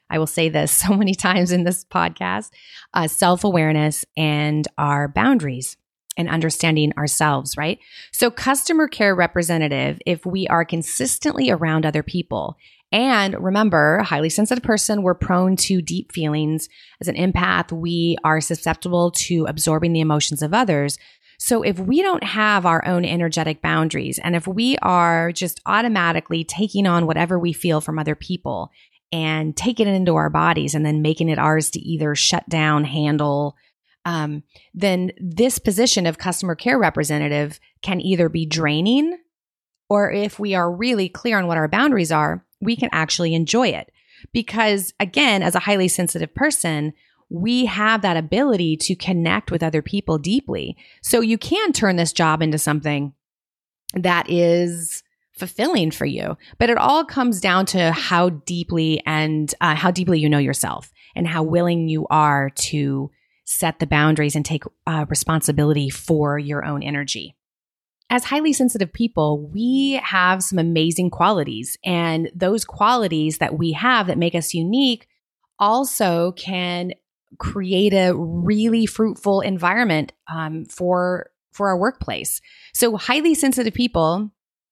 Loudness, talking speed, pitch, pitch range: -19 LUFS, 155 wpm, 175 Hz, 155-205 Hz